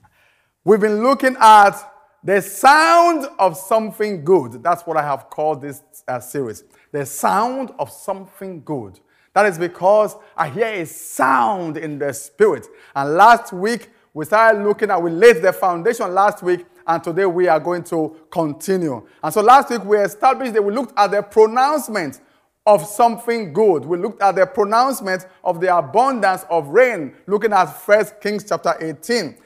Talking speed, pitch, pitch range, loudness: 170 wpm, 200 Hz, 170-225 Hz, -17 LUFS